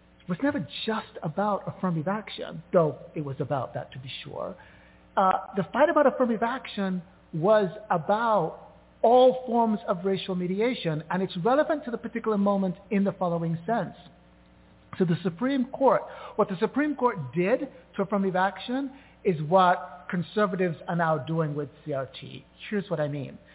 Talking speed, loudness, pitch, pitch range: 160 wpm, -27 LUFS, 190 Hz, 165-225 Hz